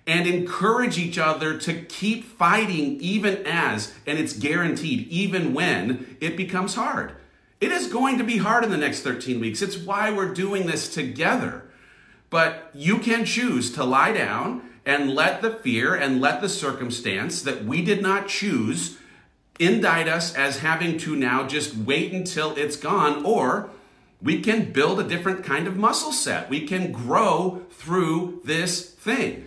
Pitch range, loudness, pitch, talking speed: 155-200 Hz, -23 LUFS, 175 Hz, 165 wpm